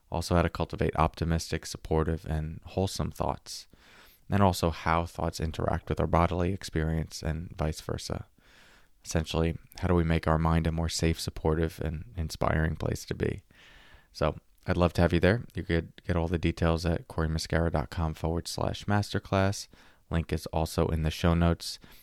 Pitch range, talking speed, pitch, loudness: 80-90 Hz, 170 wpm, 85 Hz, -30 LUFS